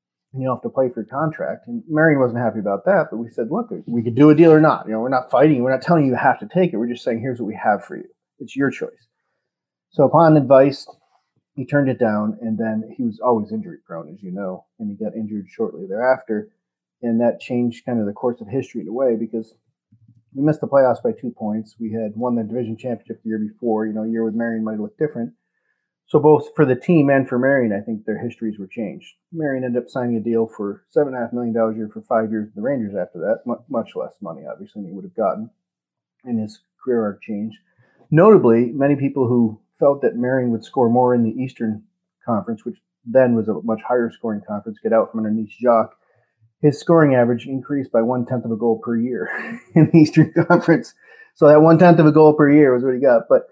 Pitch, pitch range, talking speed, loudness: 120 Hz, 110-145 Hz, 250 wpm, -18 LUFS